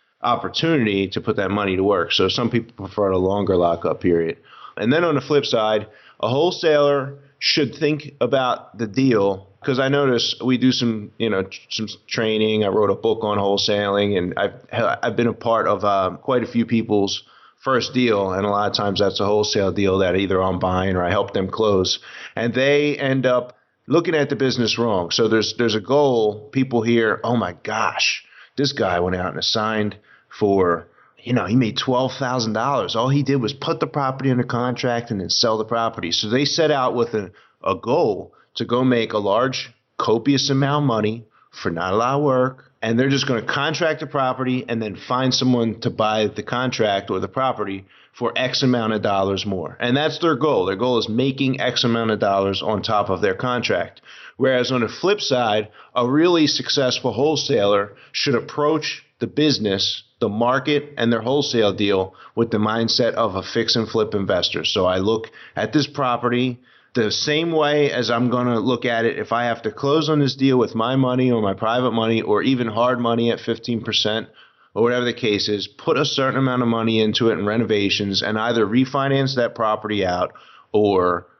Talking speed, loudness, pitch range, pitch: 205 wpm, -20 LUFS, 105-130 Hz, 115 Hz